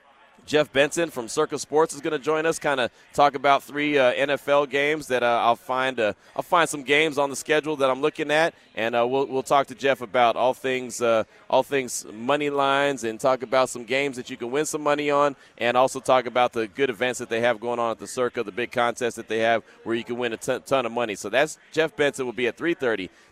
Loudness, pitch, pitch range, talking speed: -24 LUFS, 130 Hz, 120-145 Hz, 255 wpm